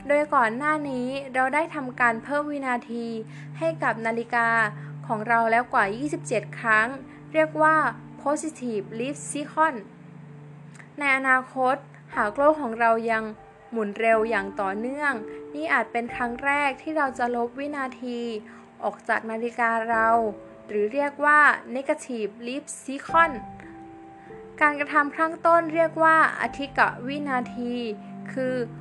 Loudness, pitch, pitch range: -24 LUFS, 240 Hz, 220-285 Hz